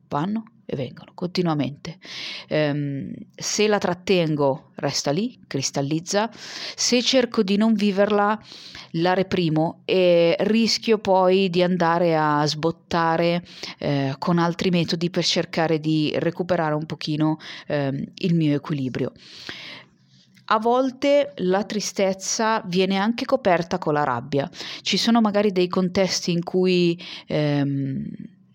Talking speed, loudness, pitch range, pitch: 120 wpm, -22 LUFS, 155-200 Hz, 175 Hz